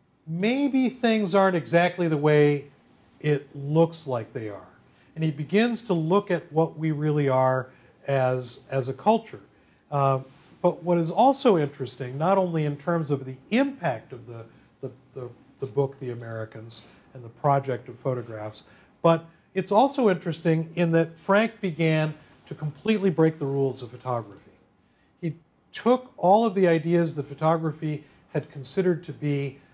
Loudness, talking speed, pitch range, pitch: -25 LUFS, 155 wpm, 130-175 Hz, 150 Hz